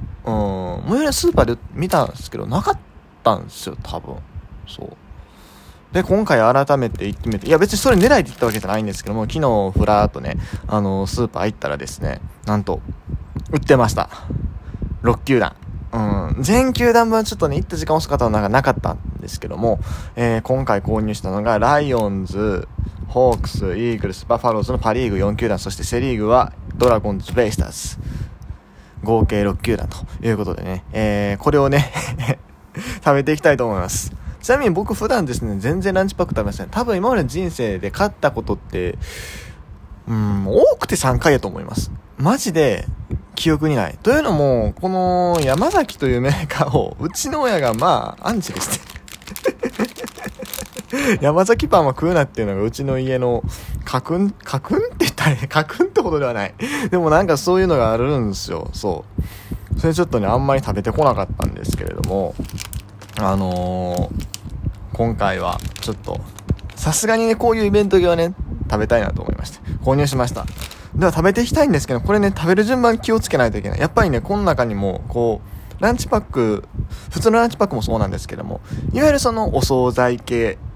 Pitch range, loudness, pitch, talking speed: 100-155 Hz, -19 LUFS, 115 Hz, 375 characters per minute